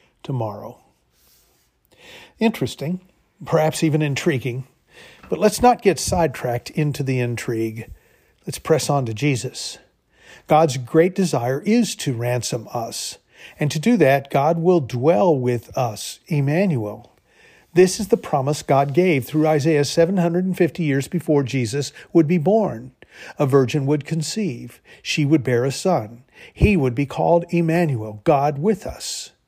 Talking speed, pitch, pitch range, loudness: 135 wpm, 150 Hz, 125-170 Hz, -20 LUFS